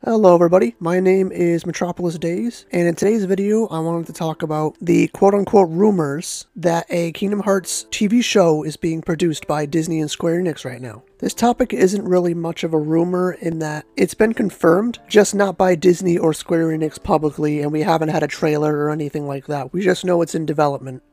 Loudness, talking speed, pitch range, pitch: -18 LUFS, 205 wpm, 155-190 Hz, 170 Hz